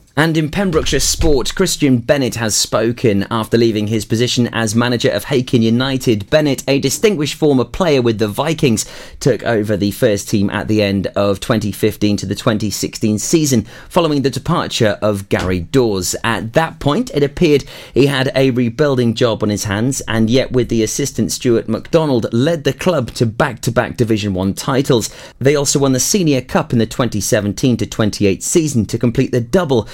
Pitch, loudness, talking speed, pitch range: 120 Hz, -15 LUFS, 180 wpm, 110-140 Hz